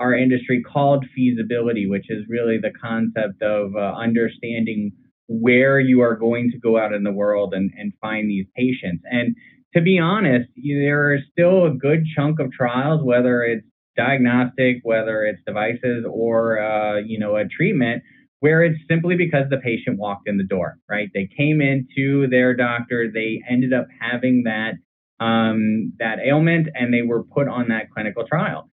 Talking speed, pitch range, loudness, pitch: 175 wpm, 110-135 Hz, -20 LUFS, 120 Hz